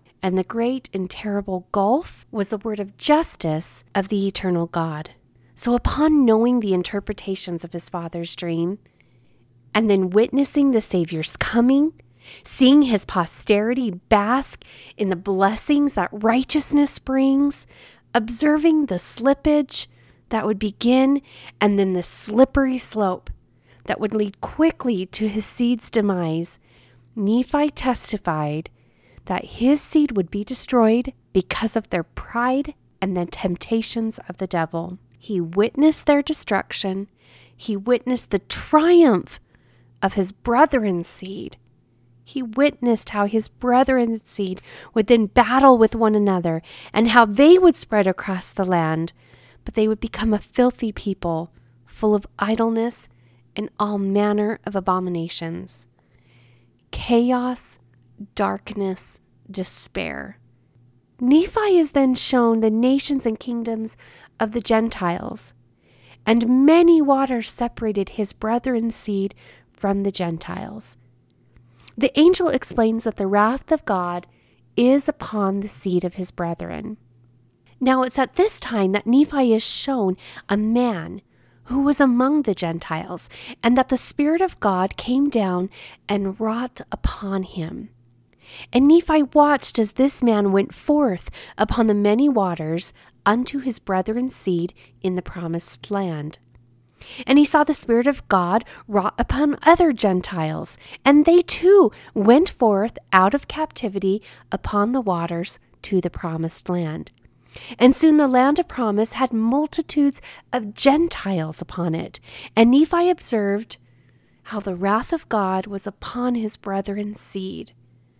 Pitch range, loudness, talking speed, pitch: 175-255 Hz, -20 LUFS, 135 wpm, 210 Hz